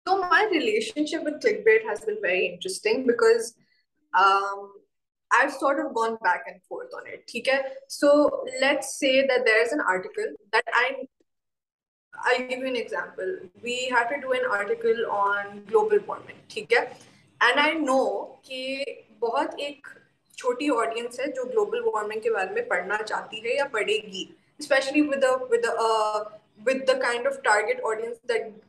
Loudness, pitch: -24 LUFS, 275 Hz